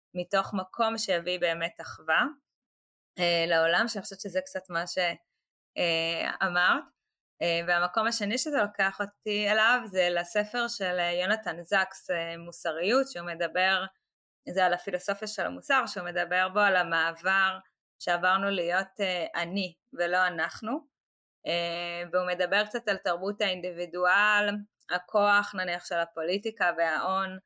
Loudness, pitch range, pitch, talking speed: -28 LUFS, 175-205 Hz, 185 Hz, 125 wpm